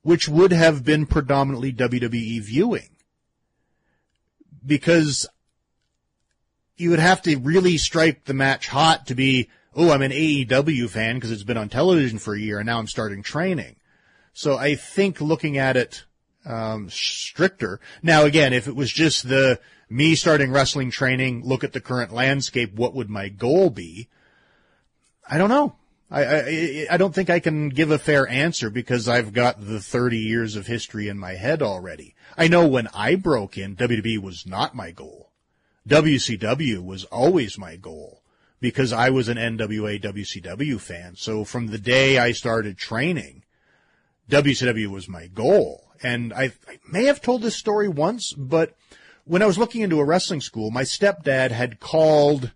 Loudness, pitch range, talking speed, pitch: -21 LUFS, 115-155 Hz, 170 wpm, 130 Hz